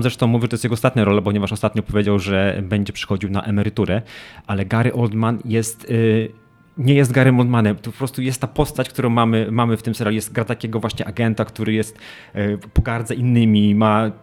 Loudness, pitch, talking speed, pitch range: -19 LUFS, 115 Hz, 205 wpm, 105-120 Hz